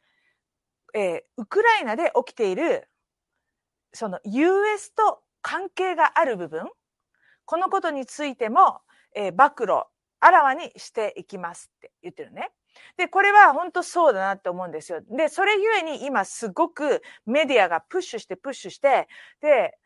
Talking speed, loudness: 305 characters per minute, -22 LUFS